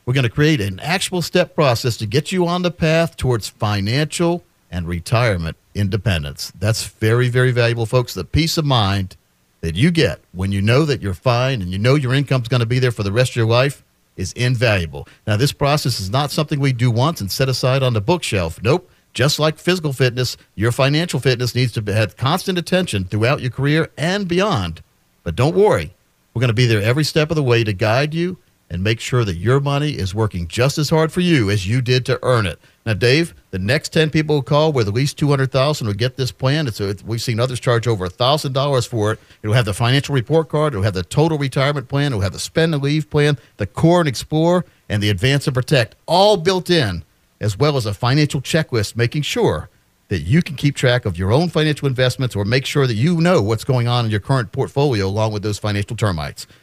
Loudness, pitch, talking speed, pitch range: -18 LUFS, 125 Hz, 230 wpm, 105-150 Hz